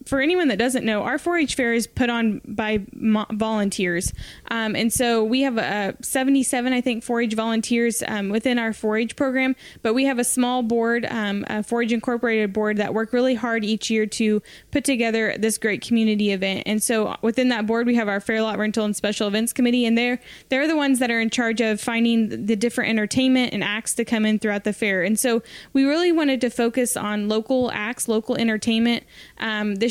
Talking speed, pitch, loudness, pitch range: 210 wpm, 230 Hz, -22 LUFS, 215-250 Hz